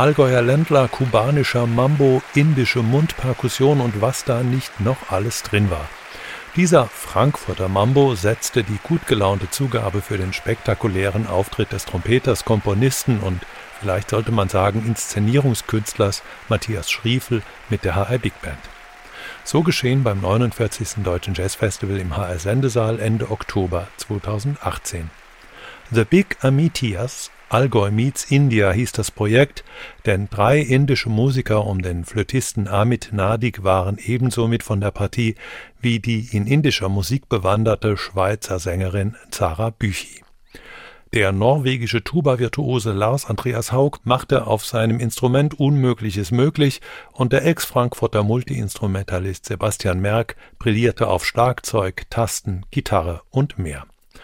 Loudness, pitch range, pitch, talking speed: -20 LUFS, 100-130 Hz, 115 Hz, 125 wpm